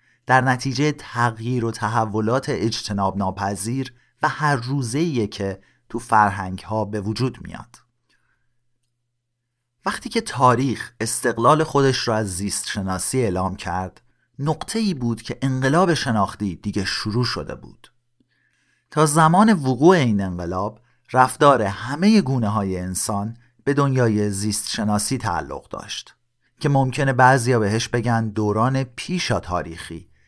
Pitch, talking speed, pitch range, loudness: 120 Hz, 125 wpm, 105-135 Hz, -21 LUFS